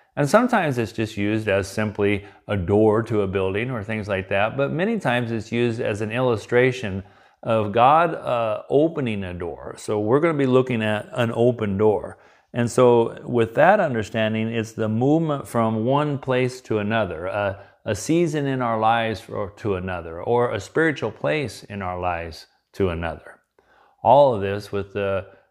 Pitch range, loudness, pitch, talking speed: 100-125 Hz, -22 LUFS, 110 Hz, 180 wpm